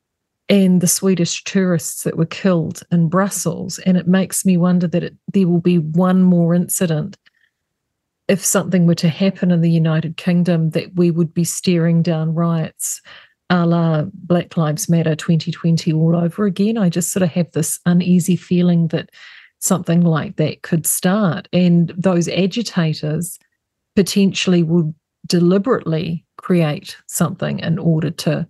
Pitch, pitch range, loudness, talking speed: 175 Hz, 165-185 Hz, -17 LUFS, 150 wpm